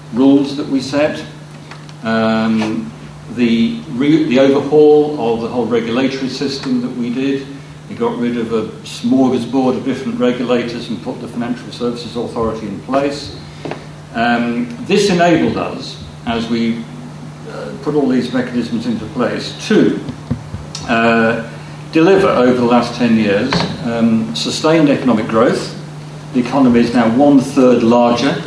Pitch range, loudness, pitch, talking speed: 115-140 Hz, -15 LUFS, 125 Hz, 140 wpm